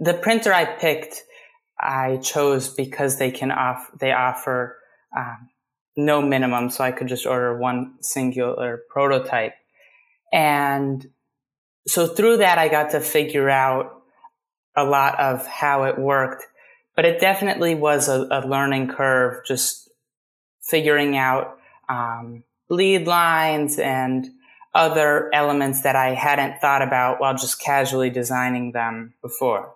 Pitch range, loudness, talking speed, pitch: 130-155 Hz, -20 LUFS, 135 wpm, 135 Hz